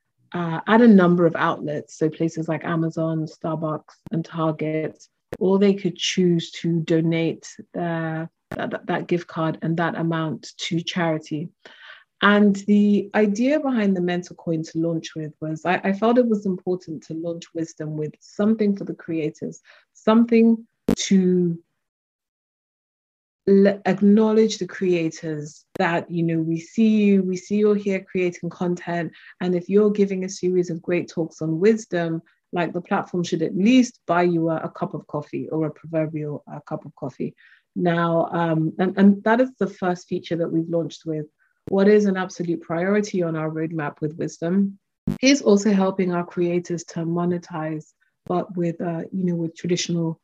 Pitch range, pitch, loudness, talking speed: 160-195 Hz, 175 Hz, -22 LUFS, 165 wpm